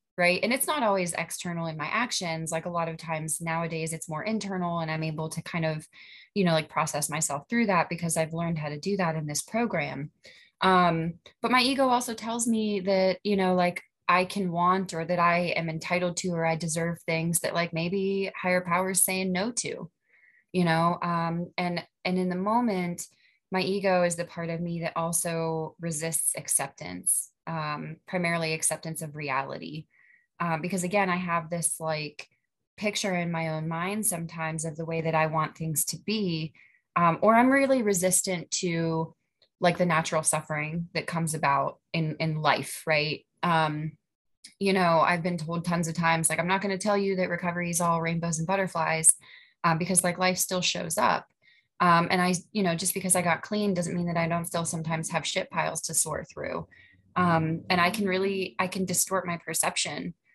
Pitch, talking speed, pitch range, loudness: 170 Hz, 200 wpm, 160-185 Hz, -27 LUFS